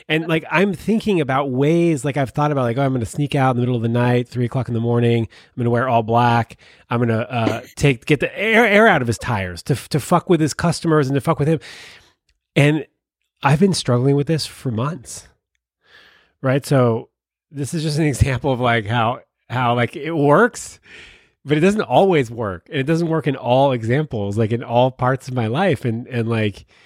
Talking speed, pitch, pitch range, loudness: 230 wpm, 130 Hz, 120-155 Hz, -18 LUFS